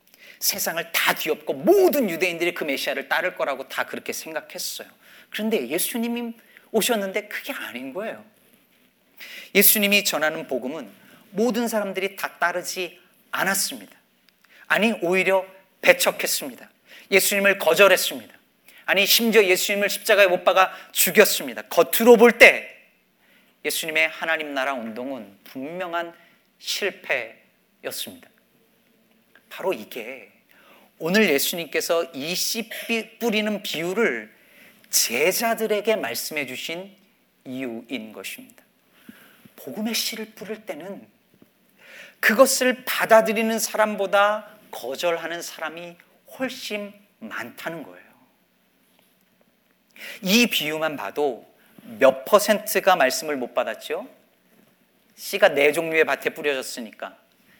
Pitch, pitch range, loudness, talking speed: 200 Hz, 170-220 Hz, -21 LUFS, 260 characters per minute